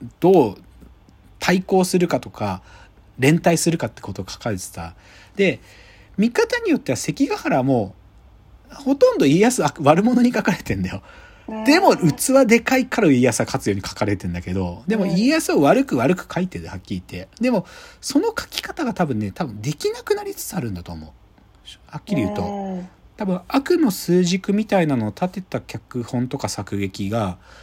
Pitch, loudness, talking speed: 165 Hz, -20 LUFS, 335 characters per minute